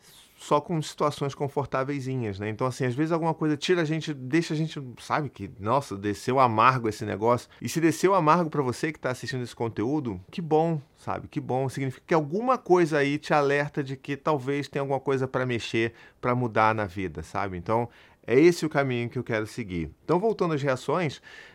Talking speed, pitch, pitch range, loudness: 205 wpm, 135 Hz, 120-155 Hz, -27 LUFS